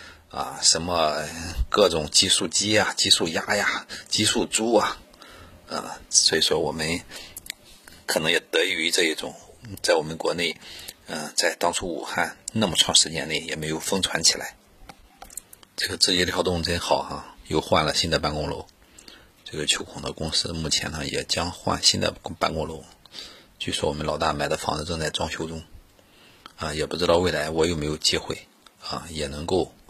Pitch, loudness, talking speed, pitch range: 80 Hz, -23 LUFS, 255 characters per minute, 75-85 Hz